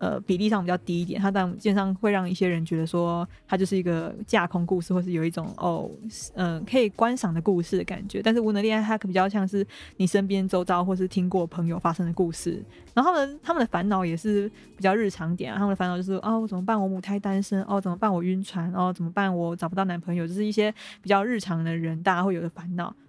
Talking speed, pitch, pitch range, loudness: 375 characters per minute, 190 Hz, 175-205 Hz, -26 LUFS